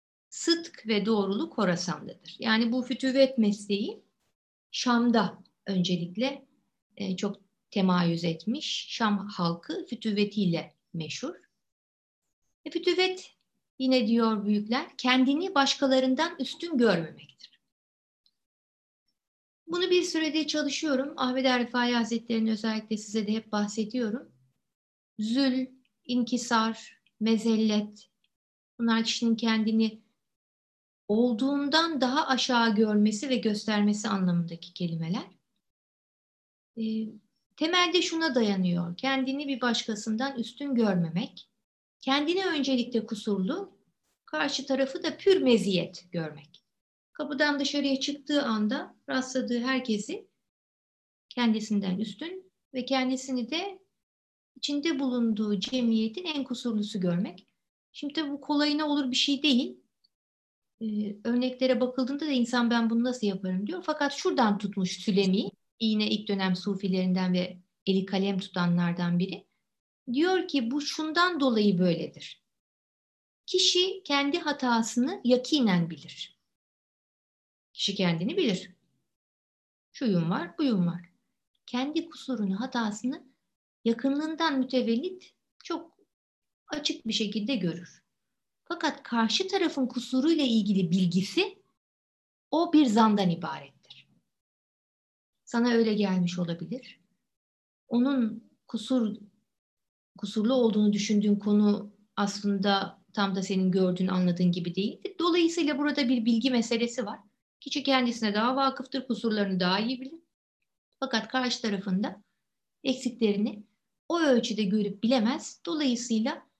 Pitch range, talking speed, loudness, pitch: 205-270 Hz, 100 wpm, -28 LUFS, 230 Hz